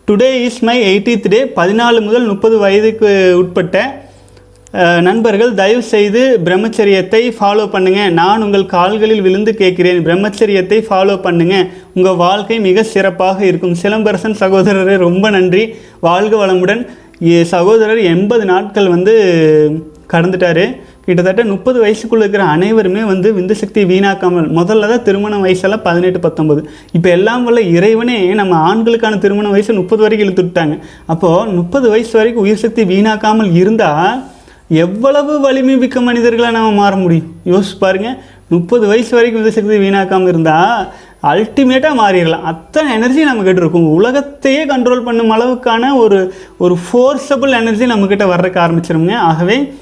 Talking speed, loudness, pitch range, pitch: 130 wpm, -10 LUFS, 180-225 Hz, 200 Hz